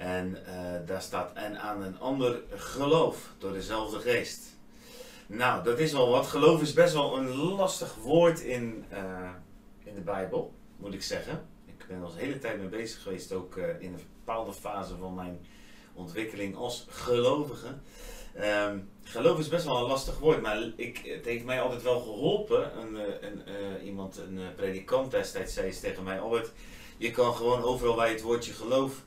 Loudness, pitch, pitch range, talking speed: -31 LUFS, 115 Hz, 95-130 Hz, 185 wpm